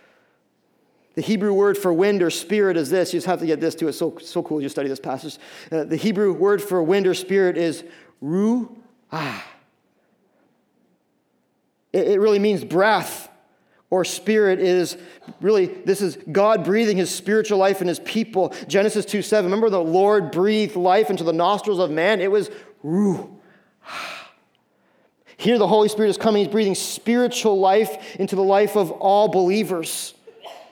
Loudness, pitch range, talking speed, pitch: -20 LUFS, 175-215 Hz, 170 wpm, 195 Hz